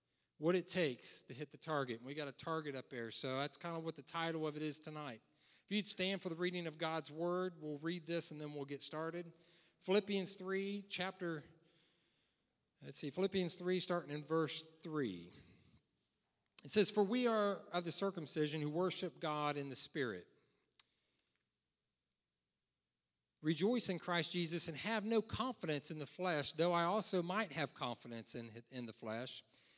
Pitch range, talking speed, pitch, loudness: 145-180 Hz, 175 wpm, 165 Hz, -40 LUFS